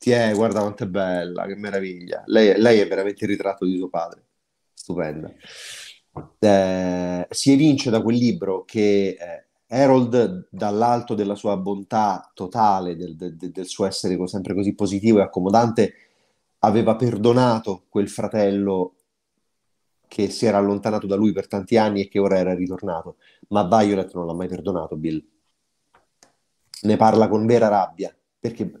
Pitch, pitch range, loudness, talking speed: 100 Hz, 95-110 Hz, -21 LUFS, 150 wpm